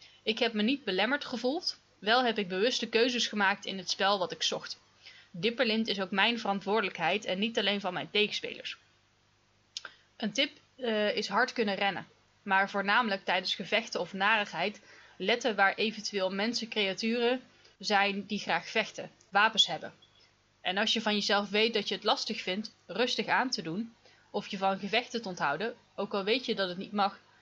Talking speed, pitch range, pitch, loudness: 175 wpm, 195-230 Hz, 210 Hz, -30 LUFS